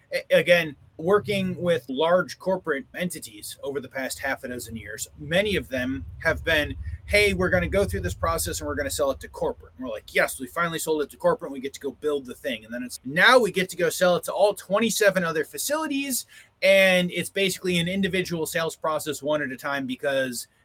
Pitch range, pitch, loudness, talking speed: 140-200 Hz, 170 Hz, -24 LUFS, 230 wpm